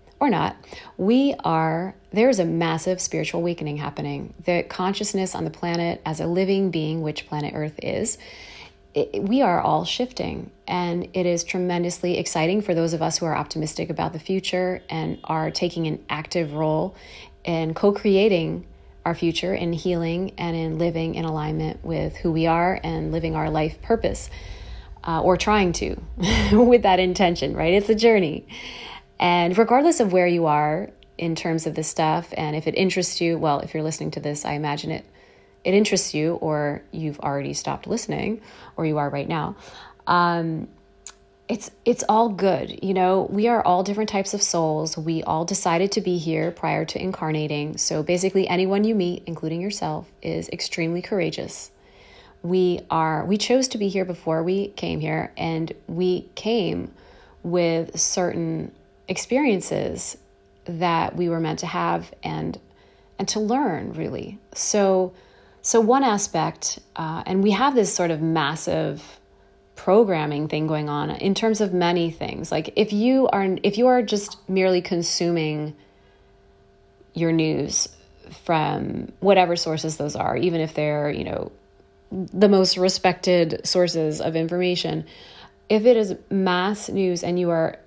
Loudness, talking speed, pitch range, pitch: -23 LUFS, 160 wpm, 155-190 Hz, 170 Hz